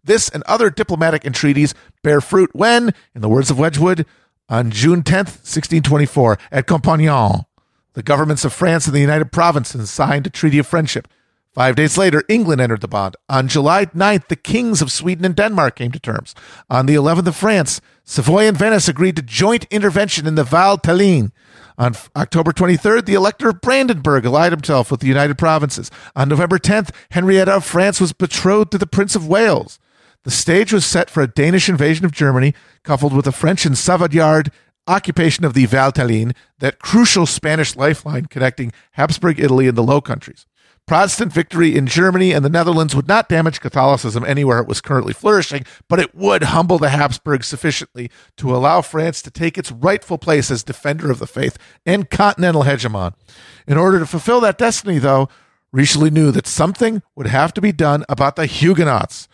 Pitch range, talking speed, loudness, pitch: 135-185 Hz, 185 wpm, -15 LUFS, 155 Hz